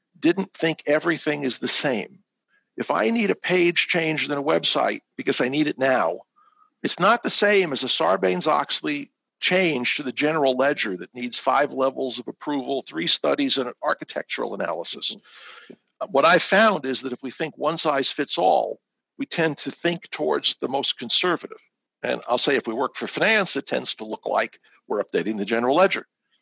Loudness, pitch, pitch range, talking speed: -22 LUFS, 155 Hz, 130-195 Hz, 190 wpm